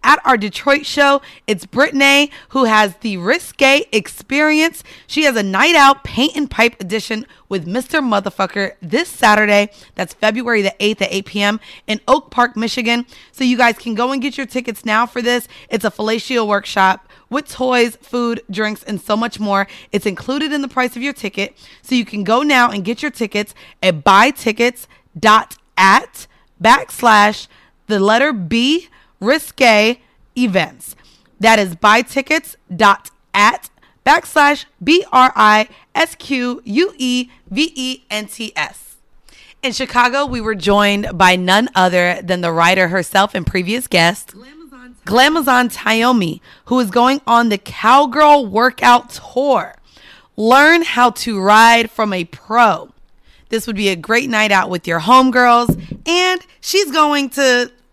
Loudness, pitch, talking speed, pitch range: -14 LUFS, 235 Hz, 145 wpm, 205-265 Hz